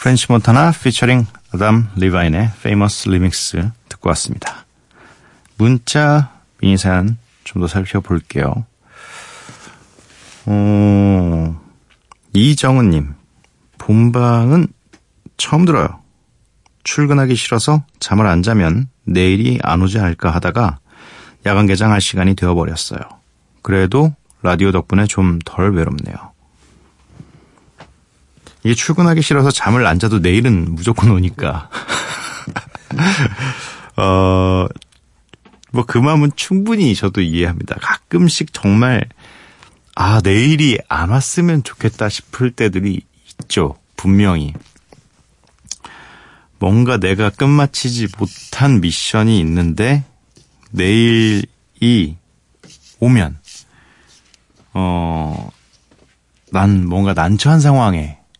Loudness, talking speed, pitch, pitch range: -14 LUFS, 205 characters per minute, 105 Hz, 90-125 Hz